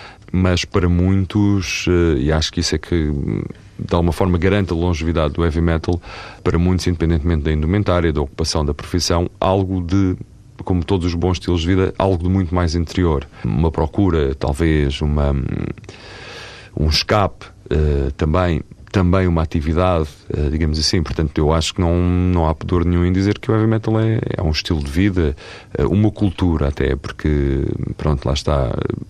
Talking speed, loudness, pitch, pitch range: 165 wpm, -18 LUFS, 85 Hz, 80-95 Hz